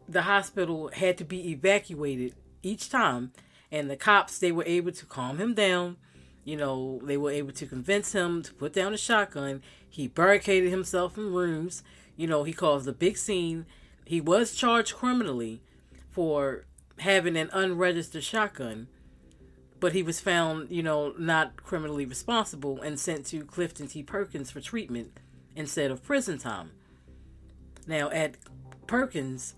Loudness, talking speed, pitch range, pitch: -28 LUFS, 155 wpm, 135-185 Hz, 160 Hz